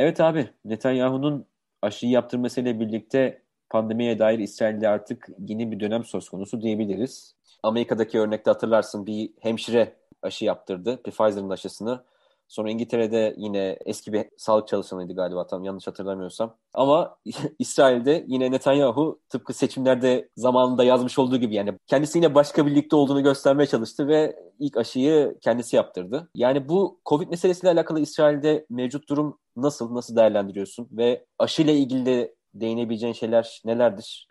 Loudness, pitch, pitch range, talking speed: -23 LUFS, 120 Hz, 110-140 Hz, 135 wpm